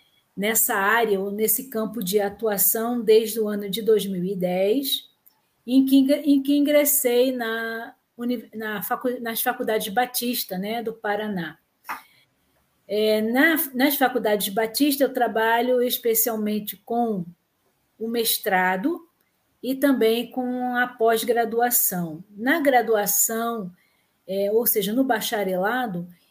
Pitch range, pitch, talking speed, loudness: 210-245 Hz, 230 Hz, 105 wpm, -22 LUFS